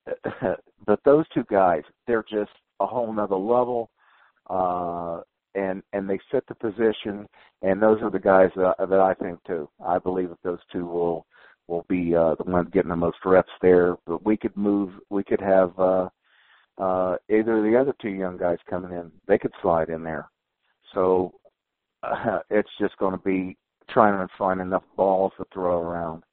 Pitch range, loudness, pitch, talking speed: 90-105 Hz, -24 LUFS, 95 Hz, 185 wpm